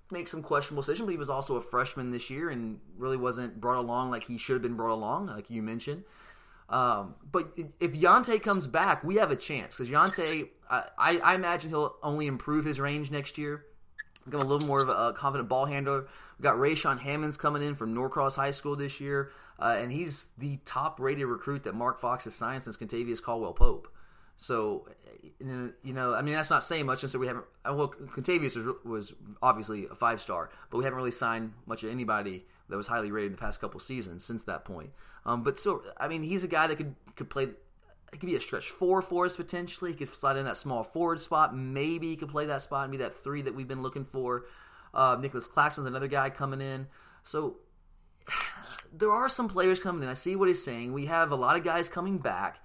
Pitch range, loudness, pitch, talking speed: 125-155 Hz, -31 LUFS, 140 Hz, 225 wpm